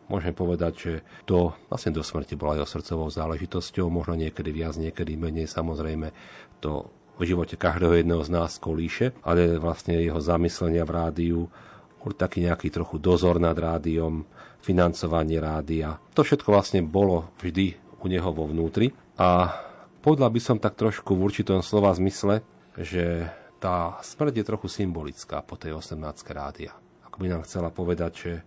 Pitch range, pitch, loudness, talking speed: 80-95 Hz, 85 Hz, -26 LUFS, 155 wpm